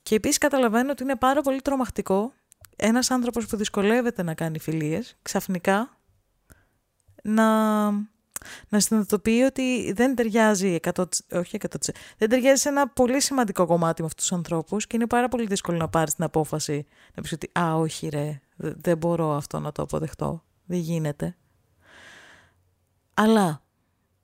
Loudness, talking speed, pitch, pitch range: -24 LUFS, 150 wpm, 190 Hz, 155-235 Hz